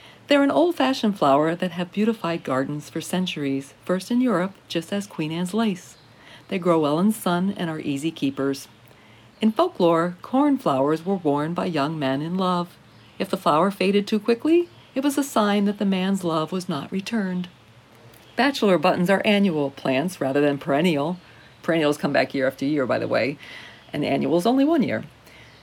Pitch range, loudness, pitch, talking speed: 145-205 Hz, -23 LUFS, 175 Hz, 185 wpm